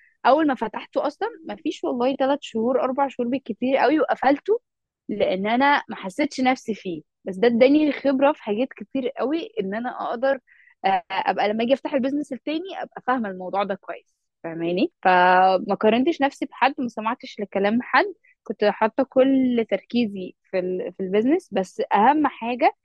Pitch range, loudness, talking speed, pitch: 205-280 Hz, -22 LUFS, 160 wpm, 255 Hz